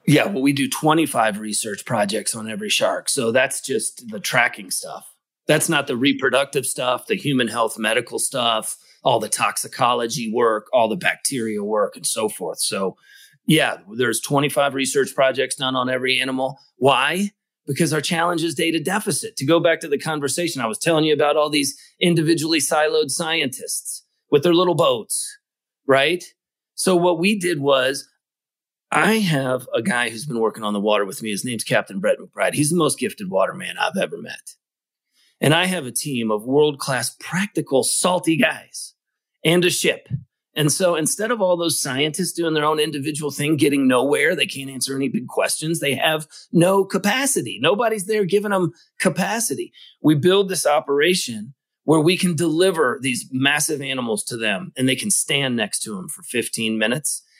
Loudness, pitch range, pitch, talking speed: -20 LUFS, 135-180 Hz, 155 Hz, 180 wpm